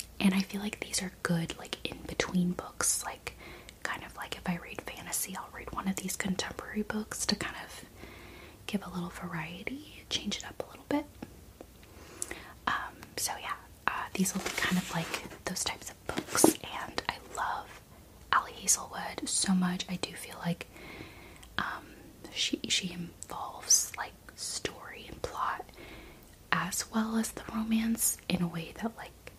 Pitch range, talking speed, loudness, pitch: 170-215 Hz, 165 wpm, -33 LUFS, 185 Hz